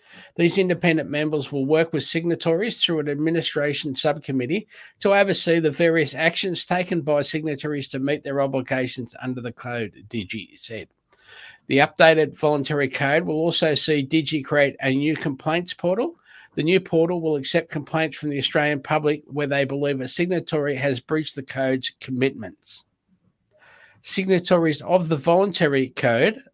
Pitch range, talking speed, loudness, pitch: 140-165 Hz, 150 wpm, -21 LUFS, 155 Hz